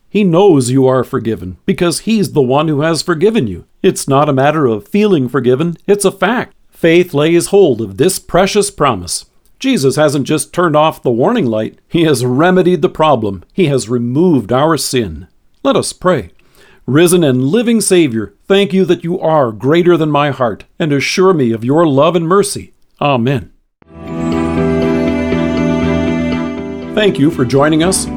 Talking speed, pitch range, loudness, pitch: 165 wpm, 120-180 Hz, -12 LUFS, 150 Hz